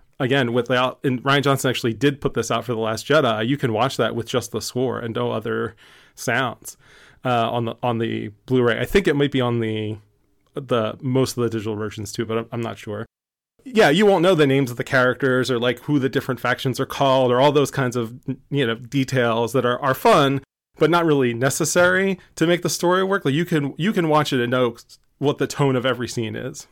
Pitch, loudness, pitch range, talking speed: 130 Hz, -20 LUFS, 115-140 Hz, 235 wpm